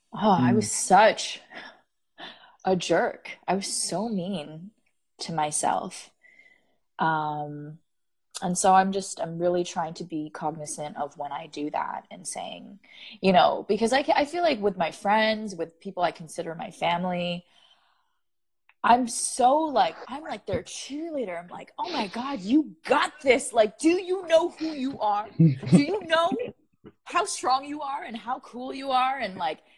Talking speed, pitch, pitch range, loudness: 160 wpm, 210 Hz, 170-280 Hz, -26 LUFS